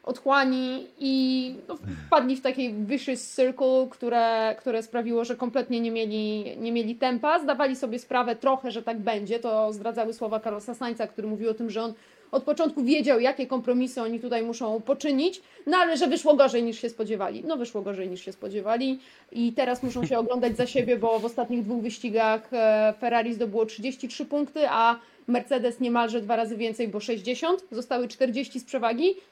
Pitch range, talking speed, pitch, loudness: 230-265 Hz, 180 wpm, 245 Hz, -26 LUFS